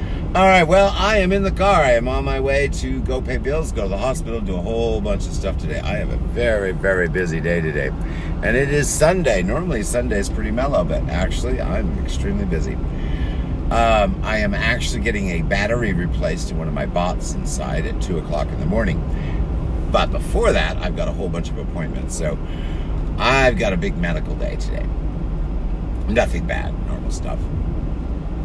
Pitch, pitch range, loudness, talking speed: 85 Hz, 80-115 Hz, -20 LUFS, 195 wpm